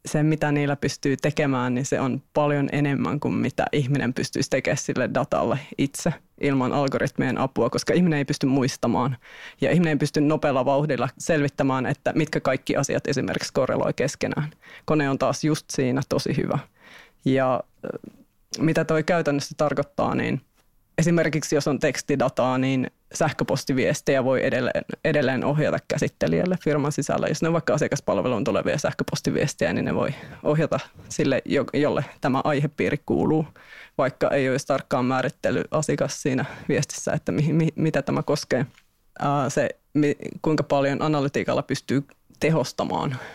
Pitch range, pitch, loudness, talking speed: 135-155 Hz, 145 Hz, -24 LUFS, 140 wpm